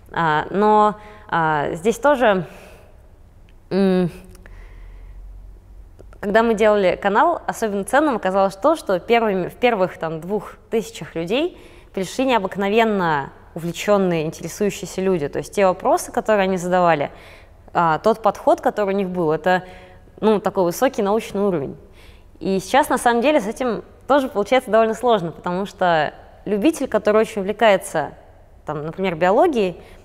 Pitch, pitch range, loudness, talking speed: 190 Hz, 160-220 Hz, -19 LUFS, 130 wpm